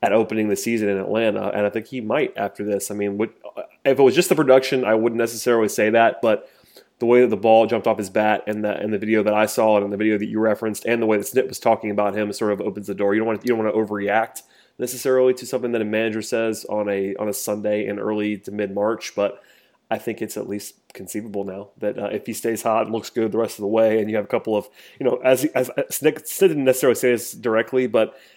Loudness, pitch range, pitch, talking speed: -21 LUFS, 105-115 Hz, 110 Hz, 280 wpm